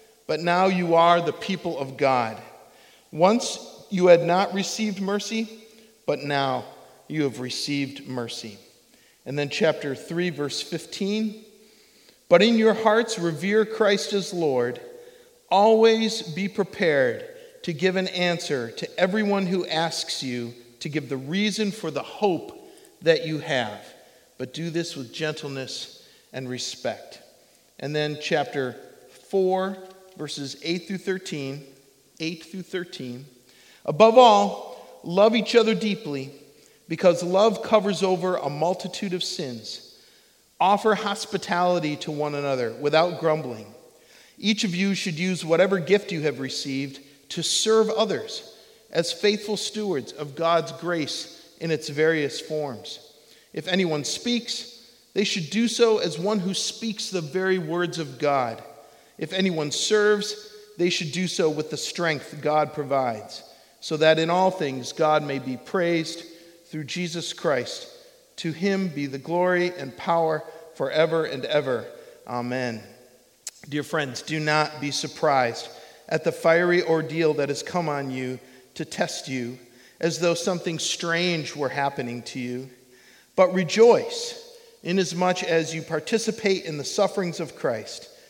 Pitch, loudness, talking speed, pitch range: 170 Hz, -24 LUFS, 140 wpm, 150-205 Hz